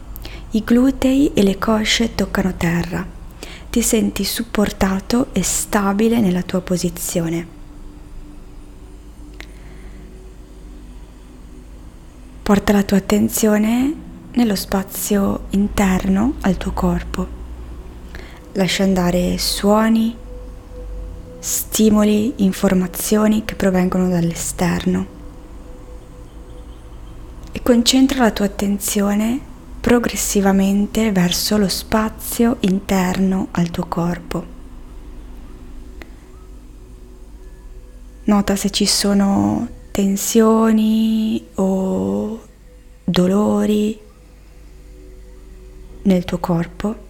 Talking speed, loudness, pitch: 70 wpm, -17 LUFS, 190 Hz